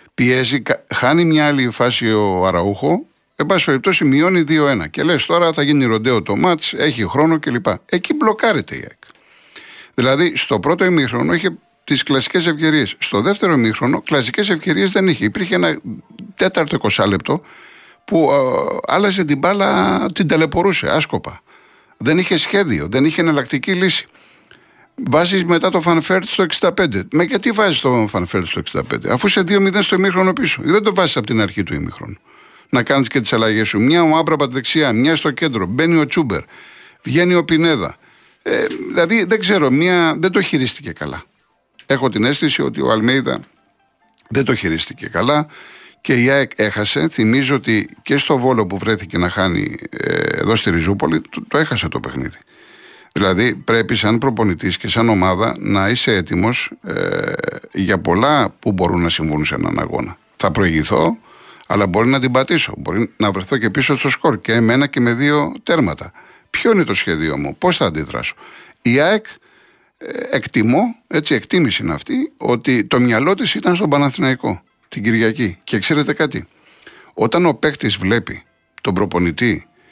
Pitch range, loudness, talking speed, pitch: 110-170 Hz, -16 LUFS, 165 wpm, 140 Hz